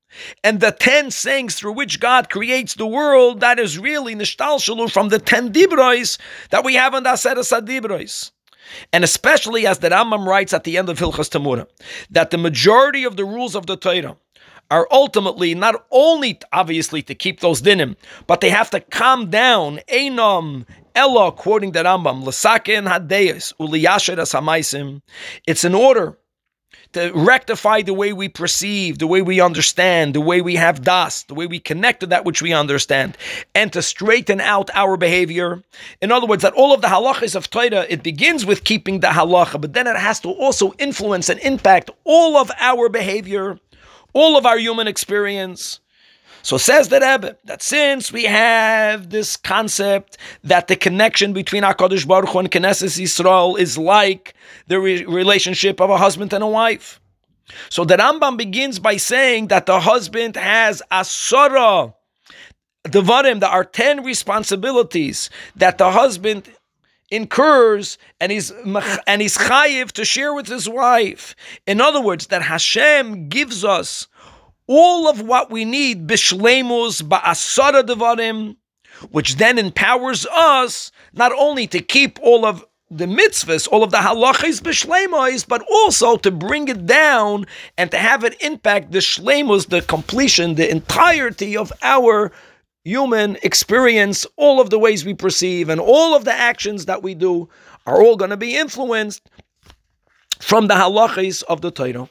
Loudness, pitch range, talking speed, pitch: -15 LUFS, 185-250 Hz, 160 wpm, 210 Hz